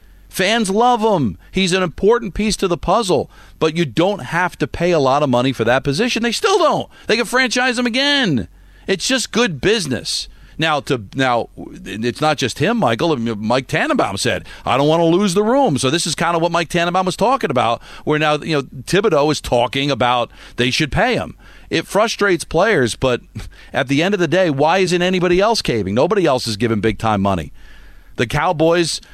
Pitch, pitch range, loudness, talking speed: 165 Hz, 130-195 Hz, -17 LUFS, 205 wpm